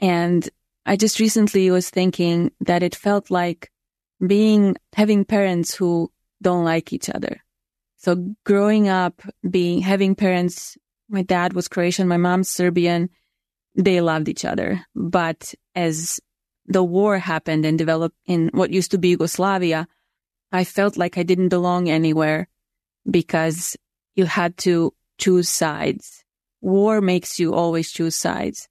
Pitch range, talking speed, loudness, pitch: 170-195 Hz, 140 wpm, -20 LUFS, 180 Hz